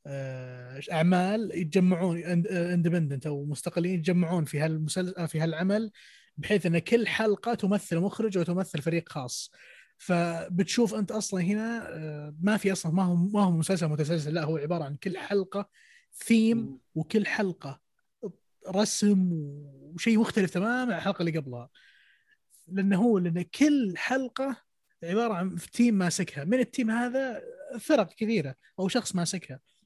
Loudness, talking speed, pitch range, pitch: -28 LUFS, 135 wpm, 165-215 Hz, 185 Hz